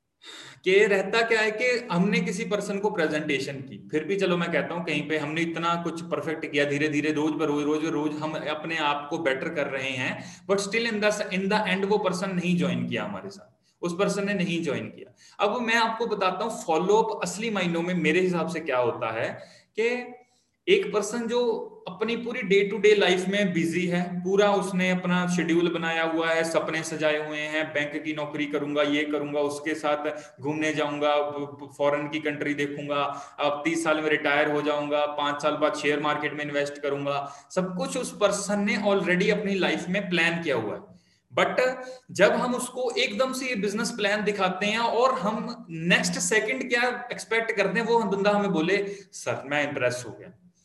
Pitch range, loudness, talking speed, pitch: 150-210 Hz, -26 LUFS, 200 wpm, 175 Hz